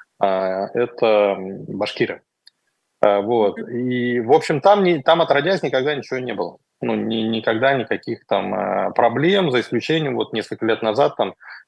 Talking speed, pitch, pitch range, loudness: 140 wpm, 120 Hz, 110-145 Hz, -19 LUFS